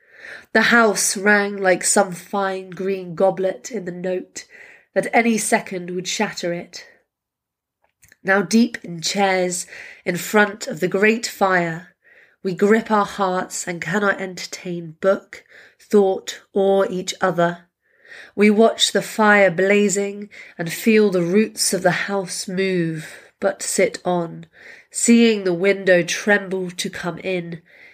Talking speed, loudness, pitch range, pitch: 135 wpm, -19 LUFS, 180-210 Hz, 195 Hz